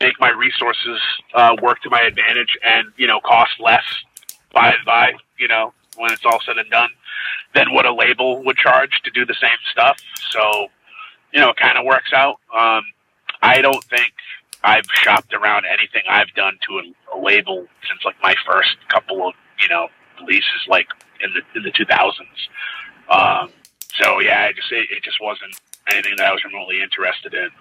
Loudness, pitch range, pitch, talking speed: -15 LUFS, 115-190 Hz, 125 Hz, 195 wpm